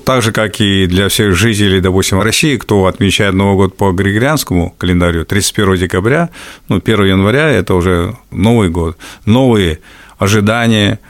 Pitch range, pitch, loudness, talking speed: 95-110 Hz, 100 Hz, -11 LUFS, 145 wpm